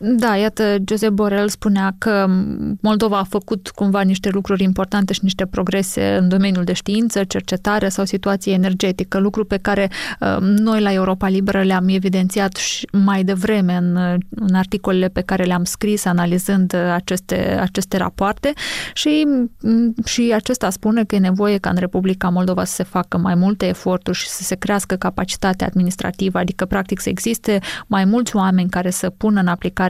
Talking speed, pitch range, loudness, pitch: 165 wpm, 185-210 Hz, -18 LUFS, 195 Hz